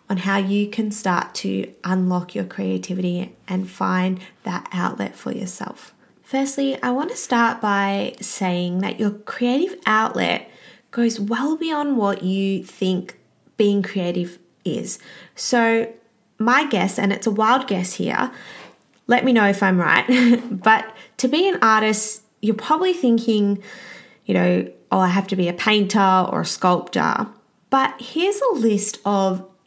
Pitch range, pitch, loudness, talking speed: 185-235 Hz, 210 Hz, -20 LUFS, 150 wpm